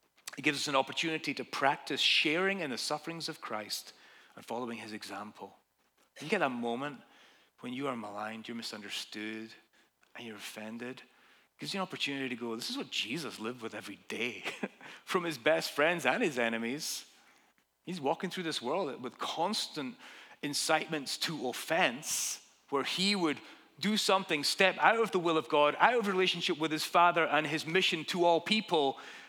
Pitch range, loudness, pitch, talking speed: 115-170 Hz, -32 LUFS, 150 Hz, 175 wpm